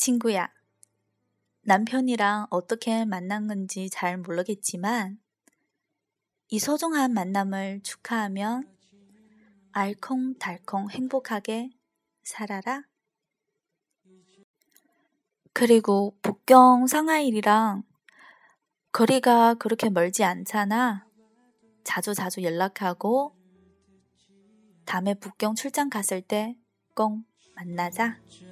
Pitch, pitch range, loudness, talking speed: 215 Hz, 195-240 Hz, -25 LUFS, 185 characters per minute